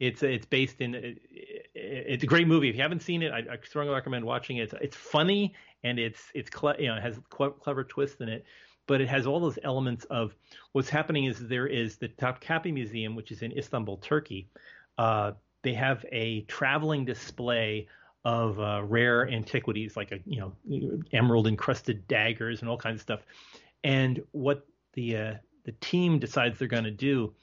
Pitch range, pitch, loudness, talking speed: 115-140 Hz, 125 Hz, -30 LUFS, 190 wpm